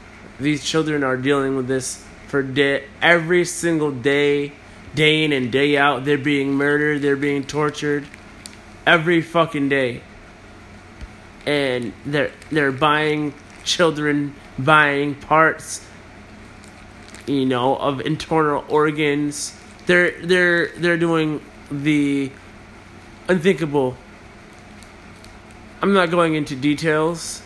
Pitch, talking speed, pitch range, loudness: 140 Hz, 105 wpm, 105-150 Hz, -19 LUFS